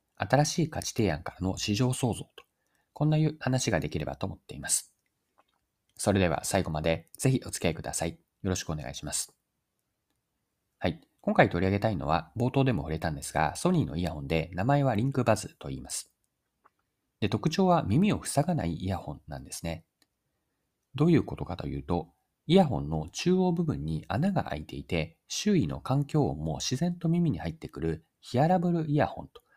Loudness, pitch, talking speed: -29 LUFS, 105 Hz, 365 characters per minute